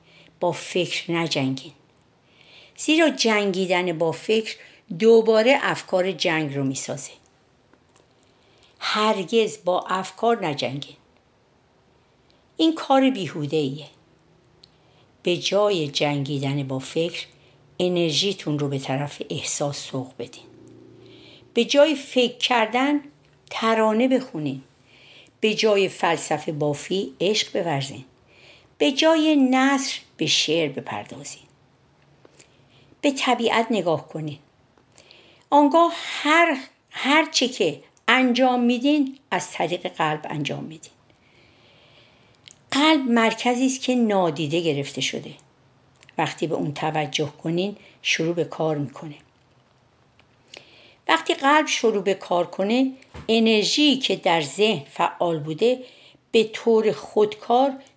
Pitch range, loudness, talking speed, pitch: 150-240 Hz, -22 LUFS, 100 wpm, 180 Hz